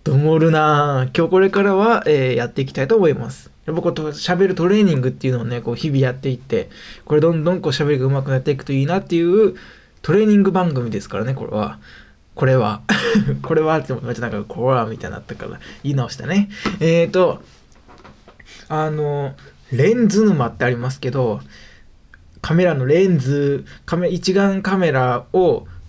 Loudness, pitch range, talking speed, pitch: -18 LUFS, 125-175 Hz, 380 characters per minute, 145 Hz